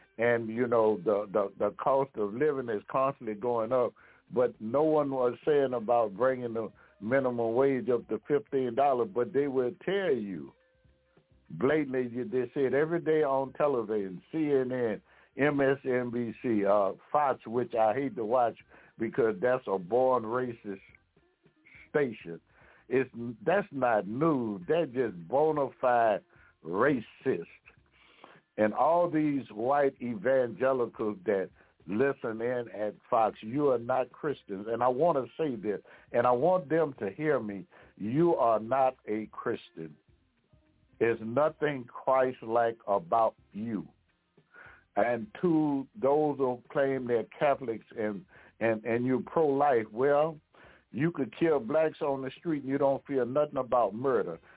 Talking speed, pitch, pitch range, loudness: 140 wpm, 125 Hz, 115-140 Hz, -30 LUFS